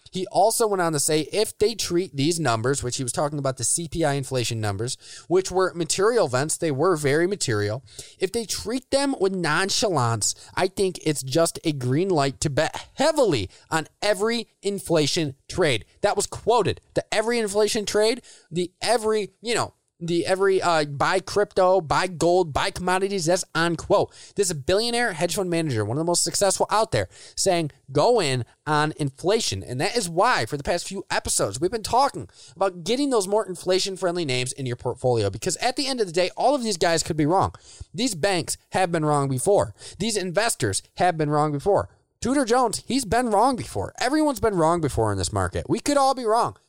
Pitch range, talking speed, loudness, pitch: 145-205 Hz, 200 wpm, -23 LUFS, 175 Hz